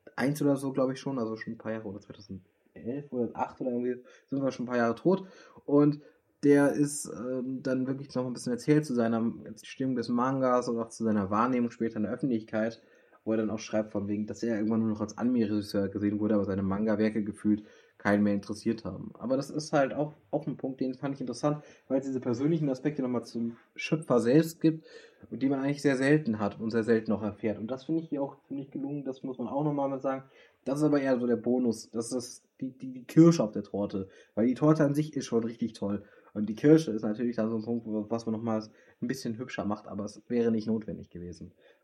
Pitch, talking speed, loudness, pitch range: 120 Hz, 240 wpm, -30 LUFS, 110-140 Hz